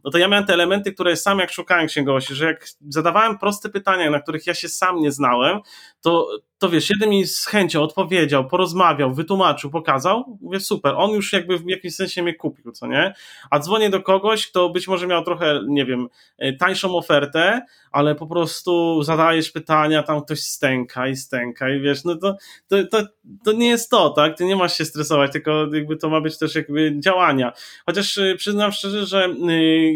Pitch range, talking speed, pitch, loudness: 155-195 Hz, 195 wpm, 170 Hz, -19 LUFS